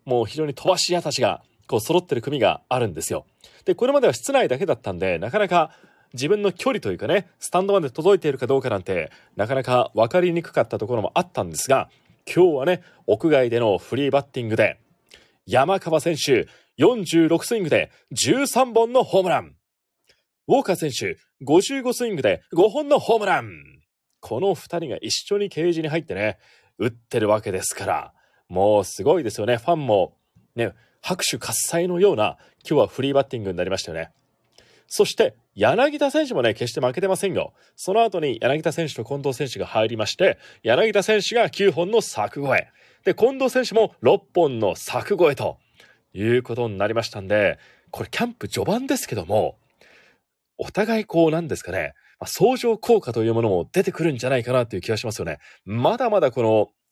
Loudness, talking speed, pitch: -22 LUFS, 350 characters per minute, 170 Hz